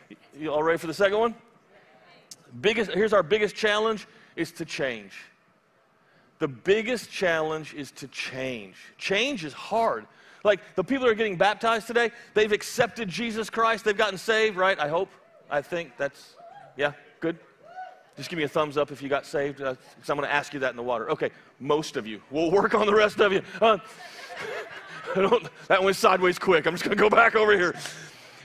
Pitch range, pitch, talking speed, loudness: 145-220 Hz, 190 Hz, 195 wpm, -25 LUFS